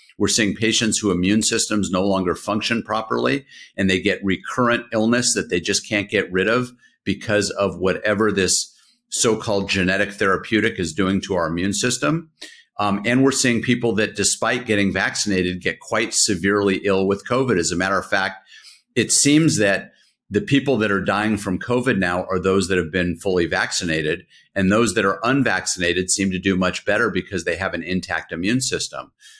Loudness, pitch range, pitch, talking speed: -20 LUFS, 95-115 Hz, 100 Hz, 185 wpm